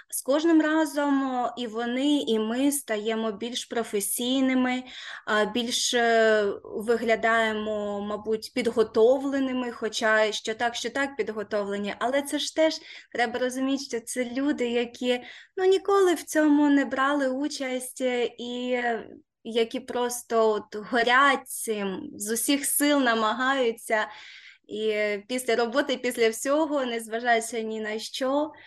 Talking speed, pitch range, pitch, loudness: 115 wpm, 225-275 Hz, 245 Hz, -26 LUFS